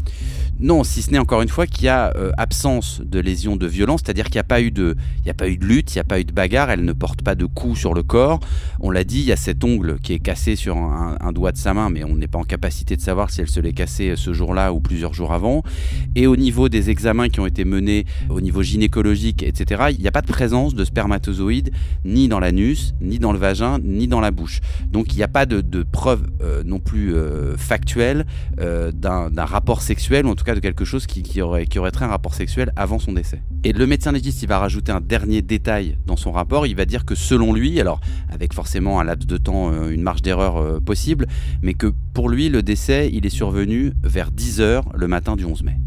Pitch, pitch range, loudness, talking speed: 85 Hz, 75-95 Hz, -20 LUFS, 250 wpm